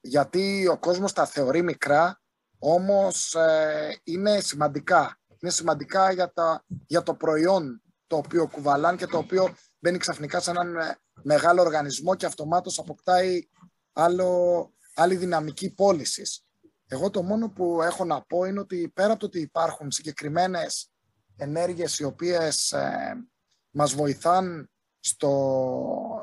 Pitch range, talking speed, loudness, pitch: 150-185 Hz, 135 wpm, -25 LUFS, 170 Hz